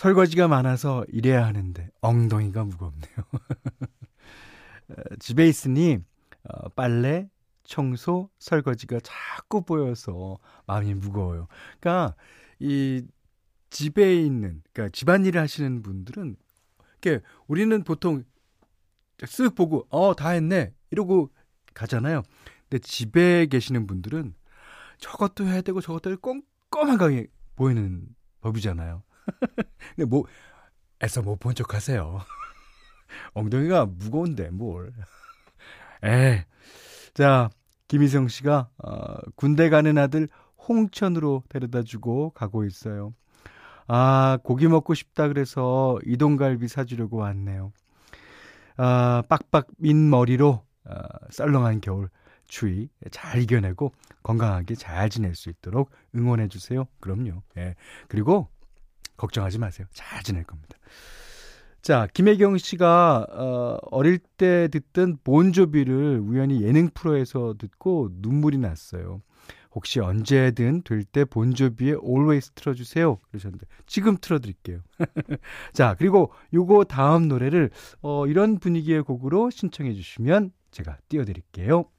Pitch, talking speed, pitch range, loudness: 130 Hz, 255 characters per minute, 105-160 Hz, -23 LUFS